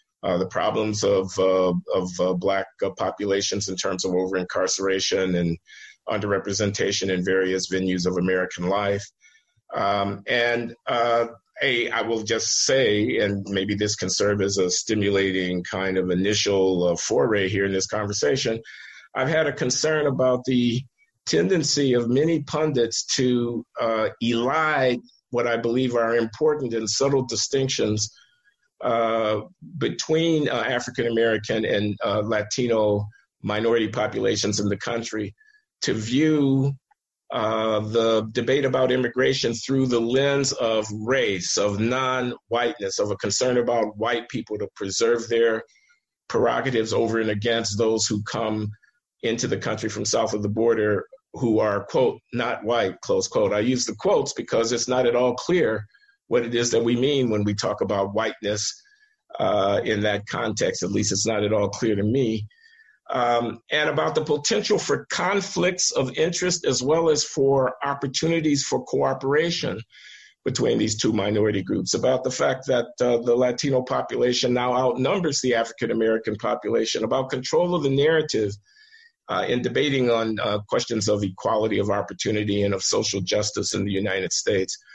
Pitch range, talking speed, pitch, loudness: 105-135 Hz, 155 wpm, 115 Hz, -23 LUFS